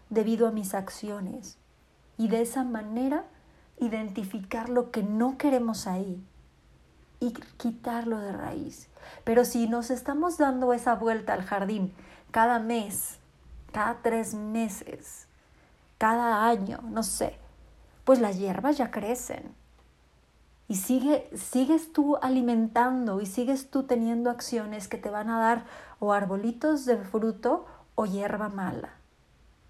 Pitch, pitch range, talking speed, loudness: 230 Hz, 210-250 Hz, 125 wpm, -28 LUFS